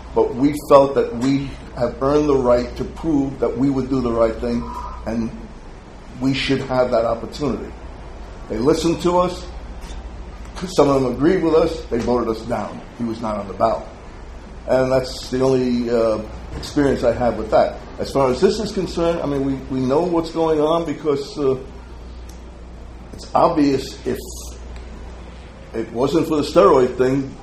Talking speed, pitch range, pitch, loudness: 175 wpm, 110-145 Hz, 130 Hz, -19 LUFS